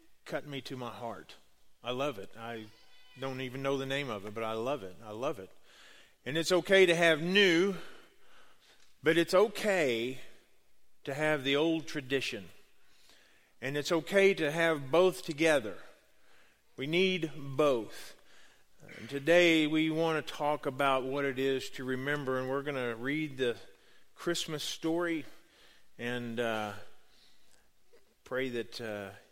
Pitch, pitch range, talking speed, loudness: 140 Hz, 125-165 Hz, 145 wpm, -31 LUFS